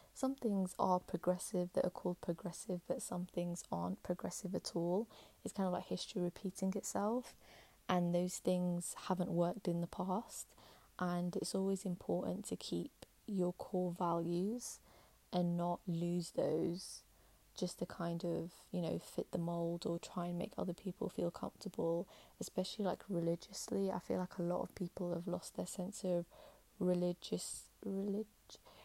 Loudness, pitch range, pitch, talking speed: -41 LUFS, 175-190 Hz, 180 Hz, 160 wpm